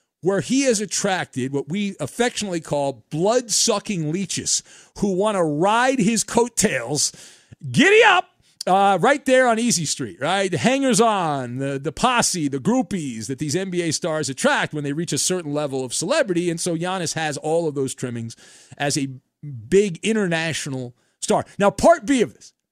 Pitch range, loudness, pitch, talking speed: 145-210 Hz, -20 LUFS, 175 Hz, 170 wpm